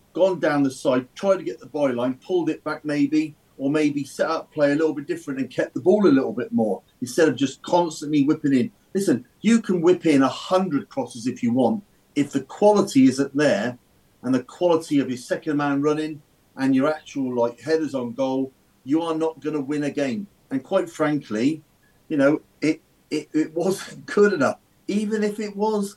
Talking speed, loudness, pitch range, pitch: 210 wpm, -23 LUFS, 140-190 Hz, 155 Hz